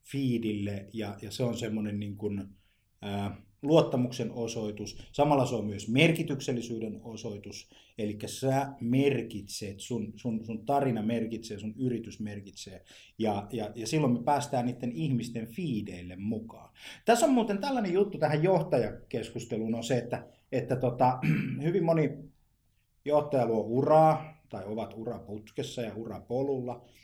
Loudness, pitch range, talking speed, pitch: -31 LUFS, 105-135 Hz, 130 wpm, 115 Hz